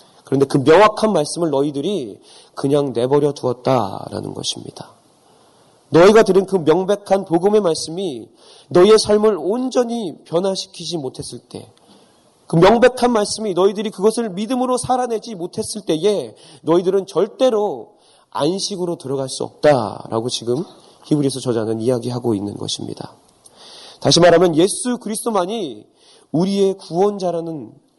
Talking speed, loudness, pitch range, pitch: 315 characters per minute, -17 LUFS, 145-215 Hz, 180 Hz